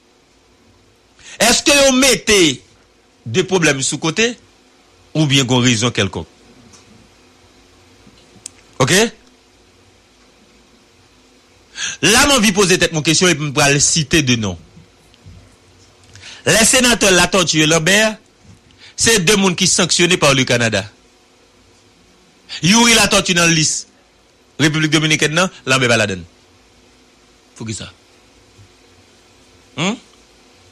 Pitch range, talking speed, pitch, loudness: 110-175 Hz, 105 wpm, 125 Hz, -13 LUFS